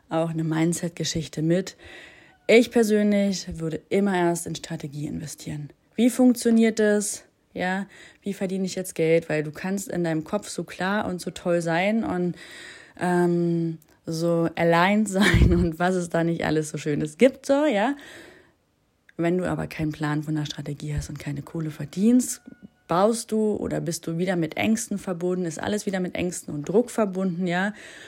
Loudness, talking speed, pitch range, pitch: -24 LUFS, 175 wpm, 160-210 Hz, 180 Hz